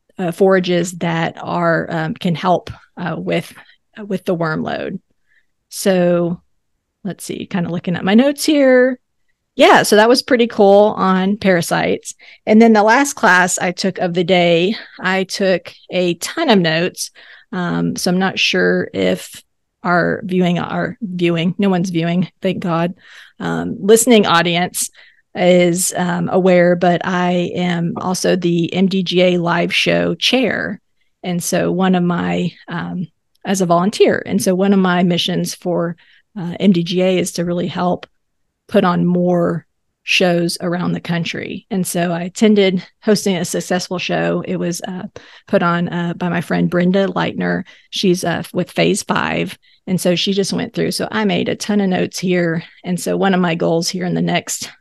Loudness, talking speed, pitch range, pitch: -16 LUFS, 170 wpm, 175-195 Hz, 180 Hz